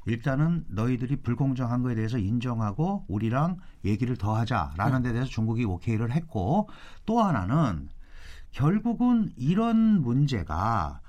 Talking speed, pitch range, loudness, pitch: 305 characters per minute, 110-160 Hz, -27 LUFS, 125 Hz